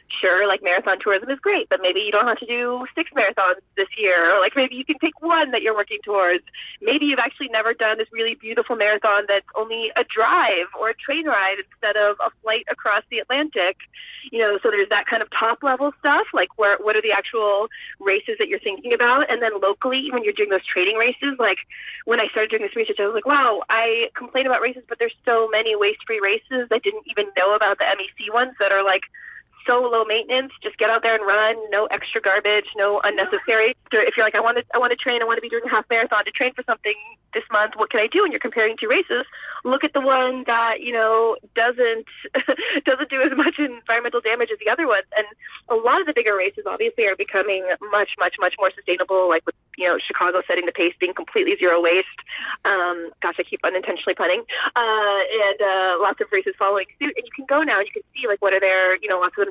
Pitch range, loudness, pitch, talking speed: 205-265 Hz, -20 LUFS, 225 Hz, 240 wpm